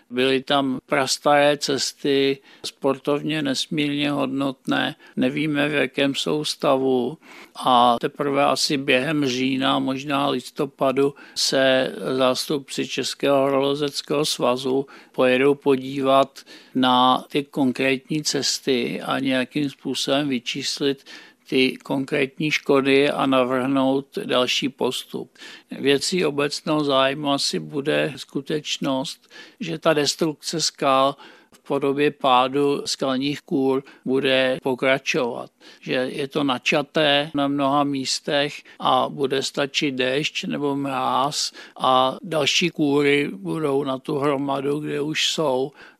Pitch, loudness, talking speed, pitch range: 140 Hz, -21 LUFS, 105 wpm, 130-145 Hz